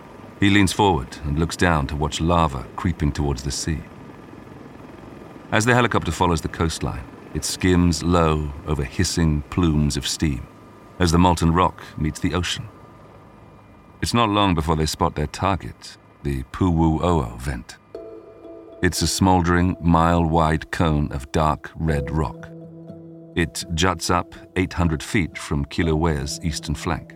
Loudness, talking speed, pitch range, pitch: -21 LUFS, 140 wpm, 75-95 Hz, 85 Hz